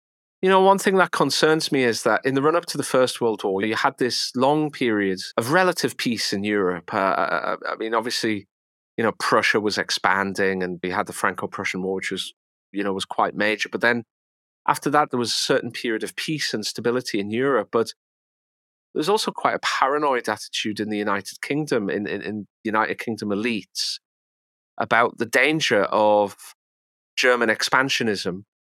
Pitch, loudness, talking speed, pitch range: 110 Hz, -22 LUFS, 185 wpm, 95-140 Hz